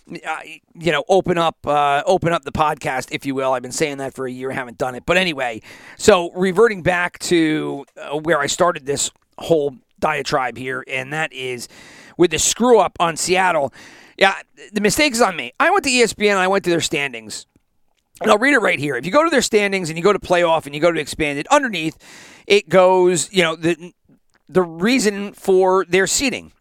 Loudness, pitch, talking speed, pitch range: -18 LUFS, 170 Hz, 215 wpm, 145-195 Hz